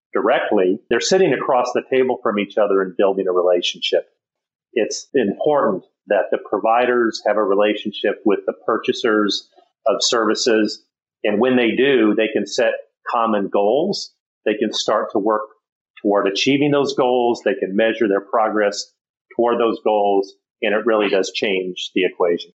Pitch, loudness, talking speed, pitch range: 105 Hz, -18 LUFS, 155 wpm, 100-120 Hz